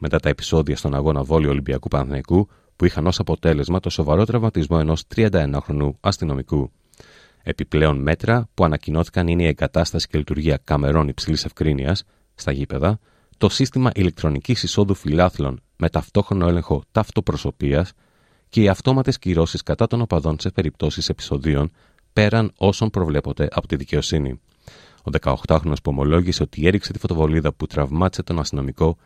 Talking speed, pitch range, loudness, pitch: 145 wpm, 75-95 Hz, -21 LUFS, 80 Hz